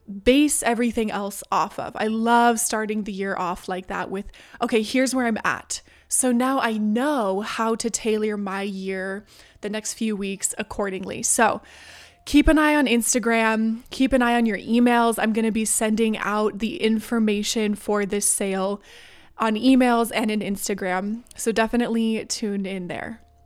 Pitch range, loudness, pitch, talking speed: 200-235 Hz, -22 LUFS, 220 Hz, 170 wpm